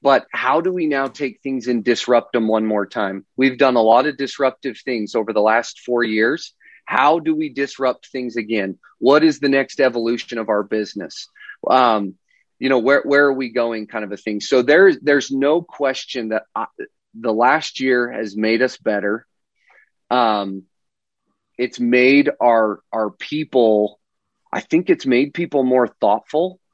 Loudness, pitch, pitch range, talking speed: -18 LUFS, 130 Hz, 115-145 Hz, 175 wpm